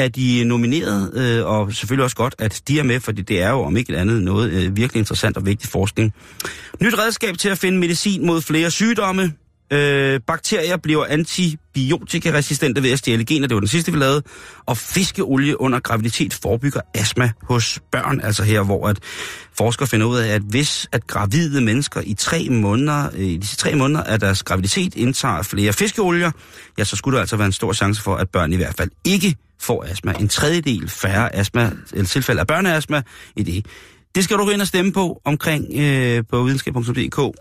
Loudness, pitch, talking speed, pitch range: -19 LUFS, 125 Hz, 195 wpm, 105-155 Hz